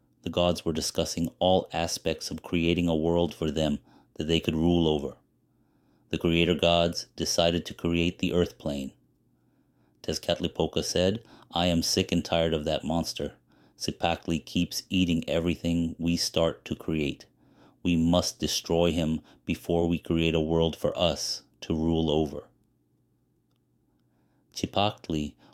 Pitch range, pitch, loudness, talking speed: 80-85 Hz, 85 Hz, -28 LUFS, 140 wpm